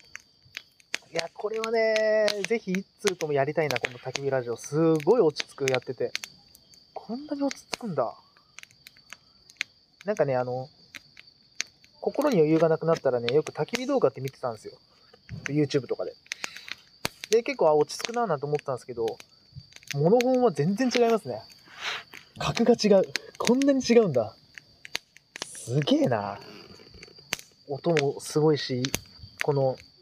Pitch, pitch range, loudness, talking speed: 160 Hz, 135-225 Hz, -27 LUFS, 295 characters per minute